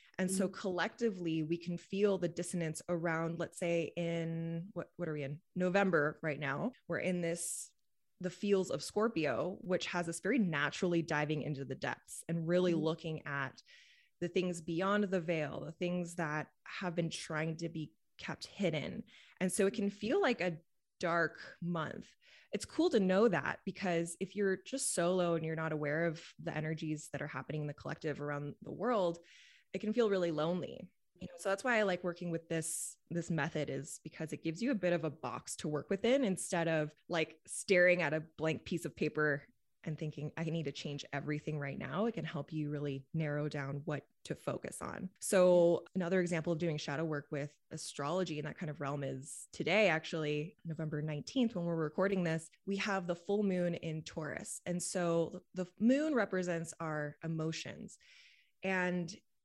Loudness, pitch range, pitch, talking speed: -36 LUFS, 155-185 Hz, 170 Hz, 190 wpm